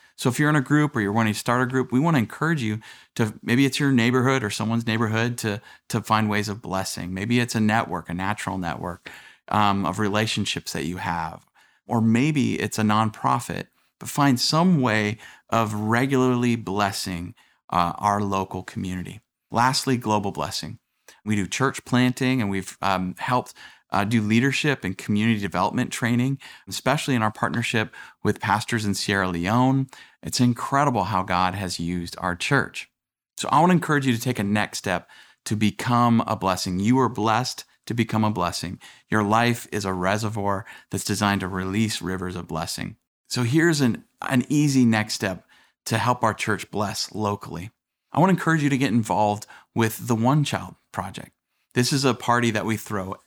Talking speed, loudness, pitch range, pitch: 185 wpm, -23 LUFS, 100-125 Hz, 110 Hz